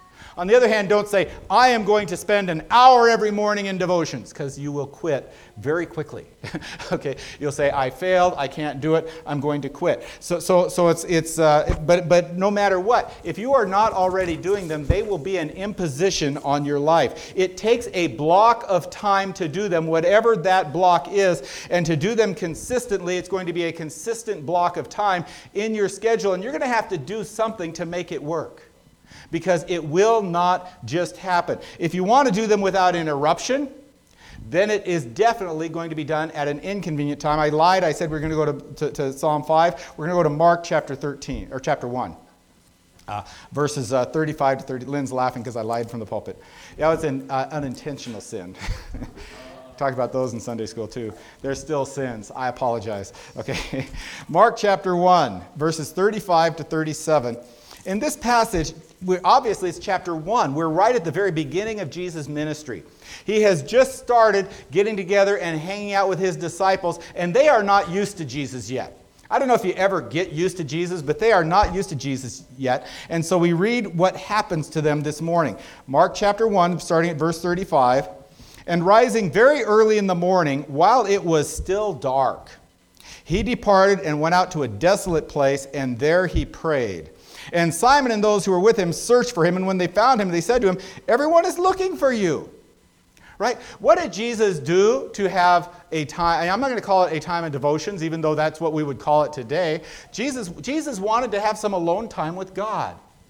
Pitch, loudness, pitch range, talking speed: 175 Hz, -21 LUFS, 150-200 Hz, 205 wpm